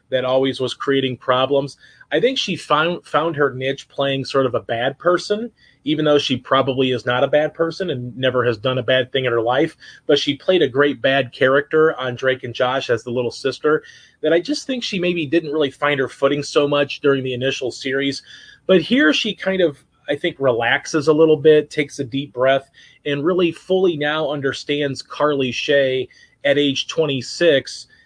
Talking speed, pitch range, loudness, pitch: 200 wpm, 130-160 Hz, -19 LUFS, 140 Hz